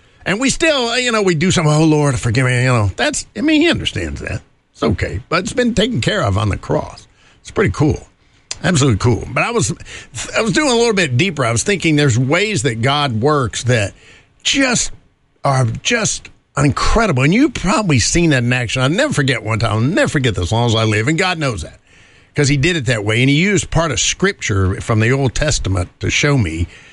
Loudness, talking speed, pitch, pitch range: -15 LUFS, 225 wpm, 140 Hz, 115-170 Hz